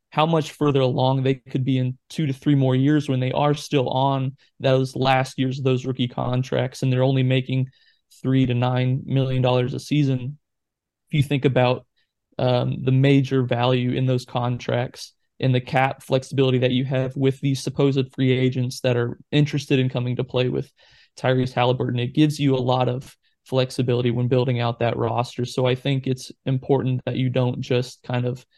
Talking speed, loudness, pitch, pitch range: 195 wpm, -22 LUFS, 130 Hz, 125-135 Hz